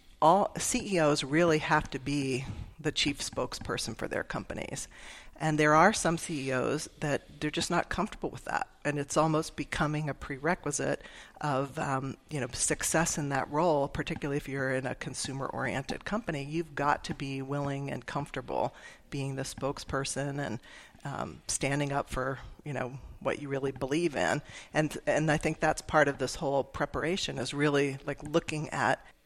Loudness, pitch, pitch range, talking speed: -31 LUFS, 145 Hz, 135-155 Hz, 180 wpm